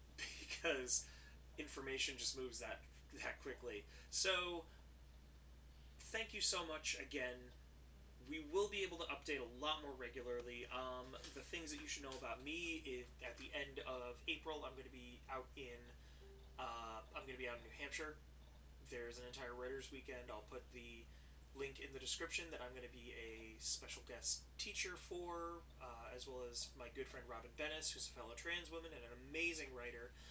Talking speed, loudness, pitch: 185 wpm, -47 LUFS, 125 Hz